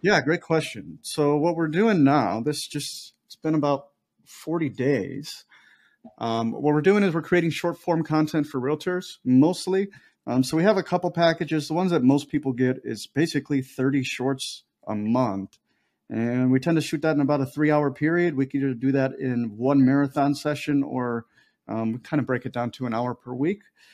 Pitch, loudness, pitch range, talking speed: 145 Hz, -24 LUFS, 130-165 Hz, 200 wpm